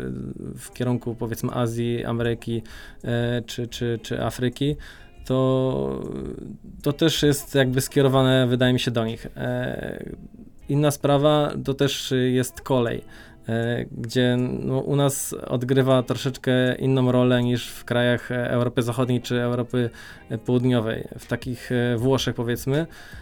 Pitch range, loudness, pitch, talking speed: 120-130 Hz, -23 LUFS, 125 Hz, 120 wpm